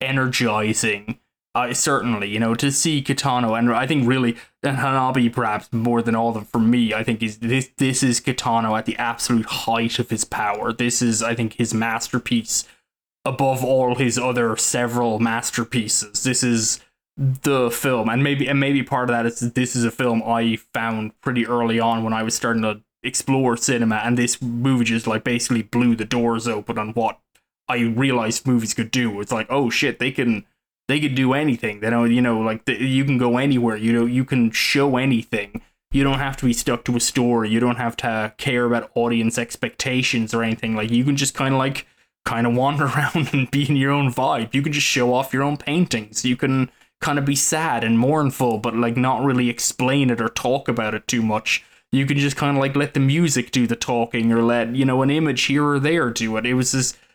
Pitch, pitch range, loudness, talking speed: 120 Hz, 115-135 Hz, -20 LUFS, 220 wpm